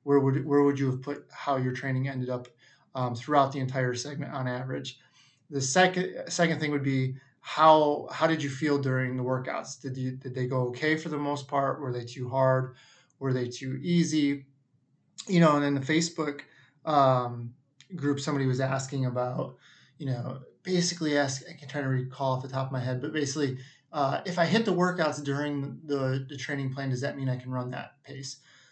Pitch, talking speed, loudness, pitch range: 140 Hz, 210 wpm, -28 LUFS, 130-145 Hz